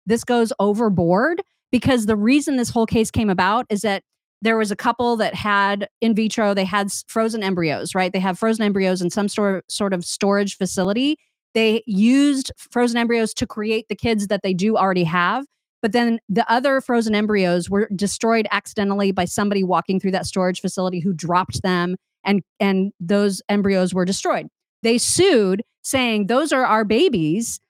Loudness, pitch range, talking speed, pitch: -20 LUFS, 190-230 Hz, 175 wpm, 205 Hz